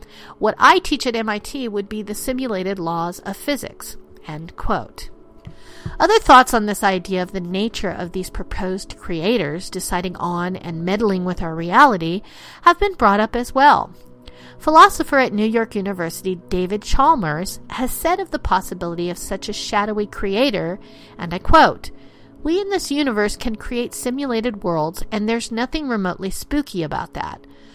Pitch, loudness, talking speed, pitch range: 205 Hz, -19 LUFS, 160 wpm, 180-245 Hz